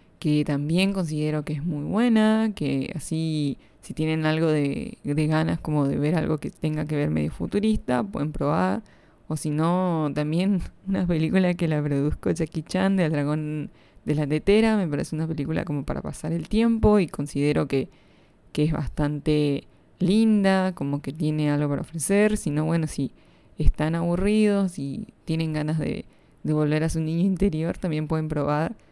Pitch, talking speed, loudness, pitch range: 155 Hz, 180 wpm, -25 LUFS, 150-180 Hz